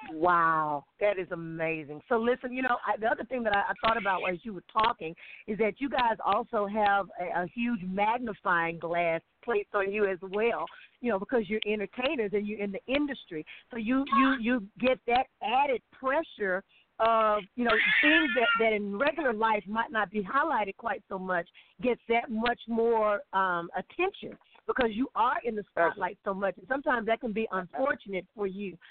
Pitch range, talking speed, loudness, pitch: 190-245 Hz, 195 wpm, -29 LUFS, 215 Hz